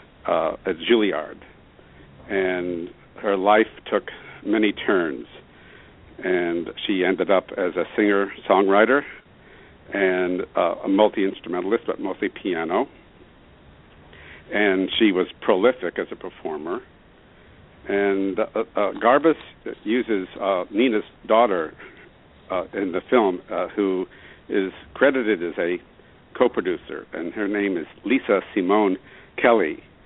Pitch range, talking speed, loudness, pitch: 90-100 Hz, 110 wpm, -22 LUFS, 95 Hz